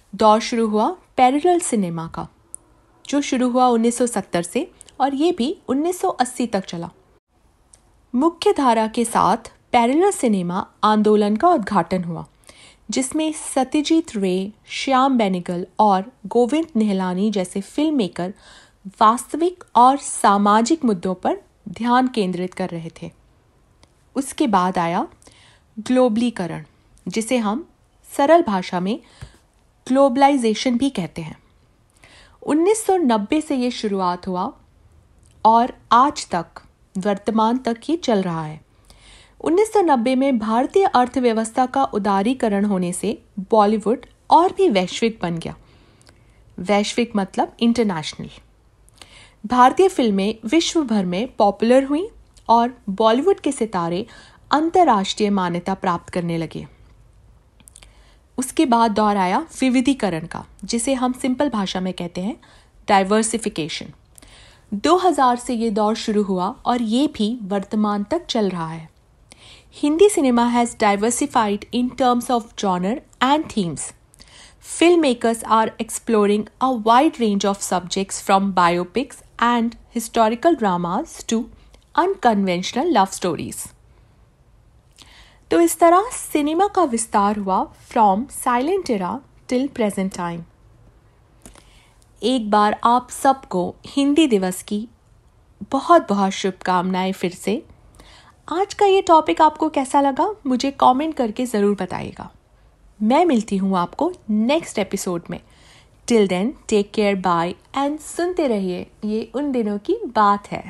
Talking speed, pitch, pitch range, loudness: 120 wpm, 225 Hz, 195-270 Hz, -19 LUFS